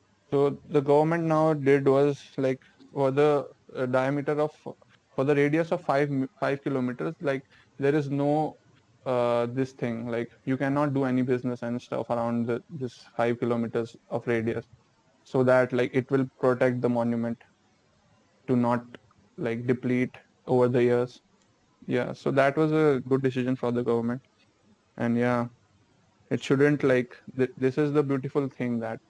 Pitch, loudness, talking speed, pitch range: 130 Hz, -27 LUFS, 160 wpm, 120-140 Hz